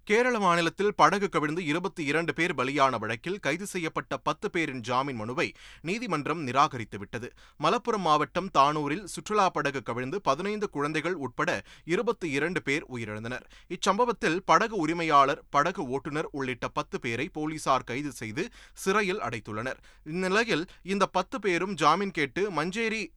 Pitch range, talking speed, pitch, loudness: 135-190 Hz, 130 wpm, 155 Hz, -28 LUFS